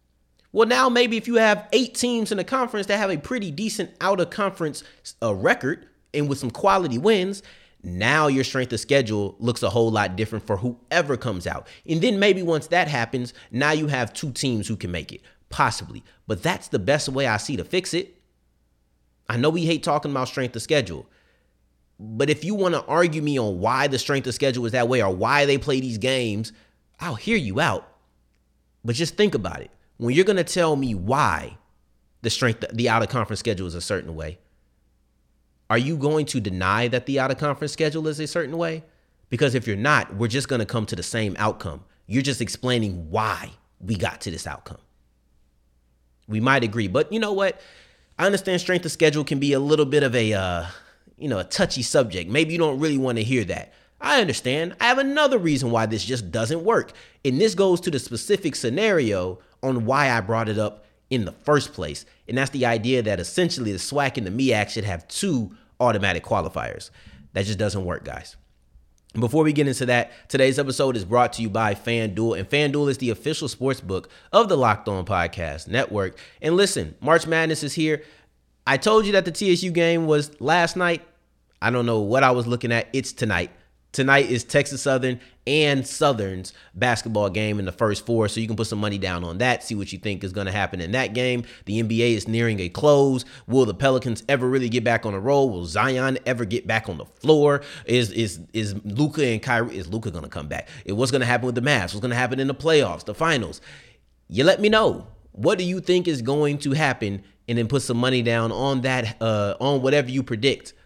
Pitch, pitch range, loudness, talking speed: 125 Hz, 105-150 Hz, -22 LUFS, 215 wpm